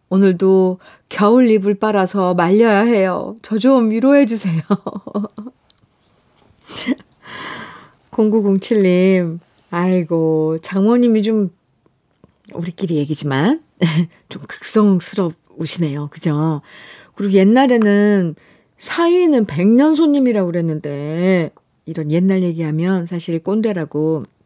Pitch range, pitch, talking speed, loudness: 165-215 Hz, 190 Hz, 210 characters per minute, -16 LUFS